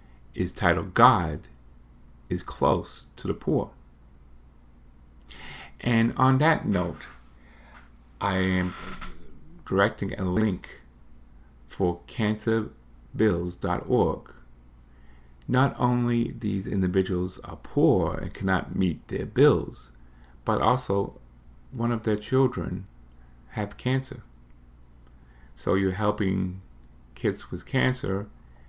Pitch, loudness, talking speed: 85 Hz, -26 LUFS, 90 wpm